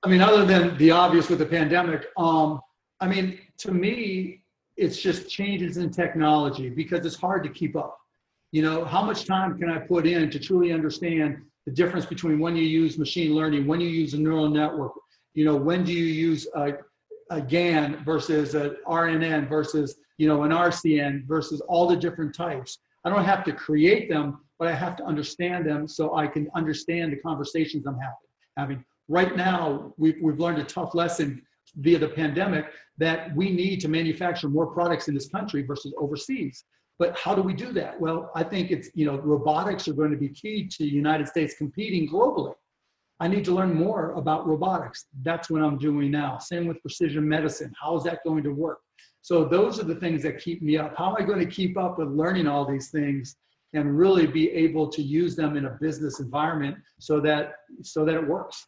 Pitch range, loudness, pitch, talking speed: 150-175 Hz, -25 LUFS, 160 Hz, 205 wpm